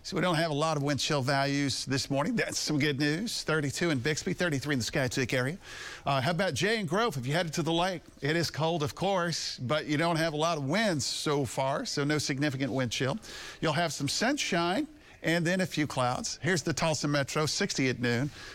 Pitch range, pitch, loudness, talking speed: 140-170 Hz, 150 Hz, -29 LUFS, 235 wpm